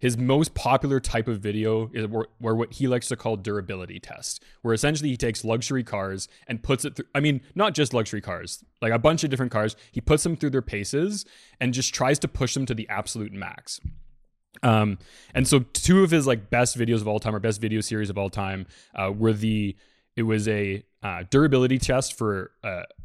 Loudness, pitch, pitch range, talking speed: -25 LUFS, 115 Hz, 105-135 Hz, 215 wpm